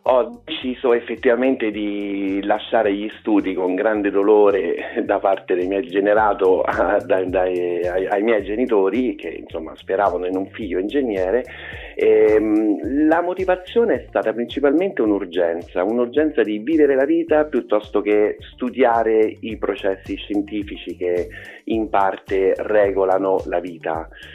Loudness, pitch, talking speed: -19 LUFS, 110 Hz, 130 wpm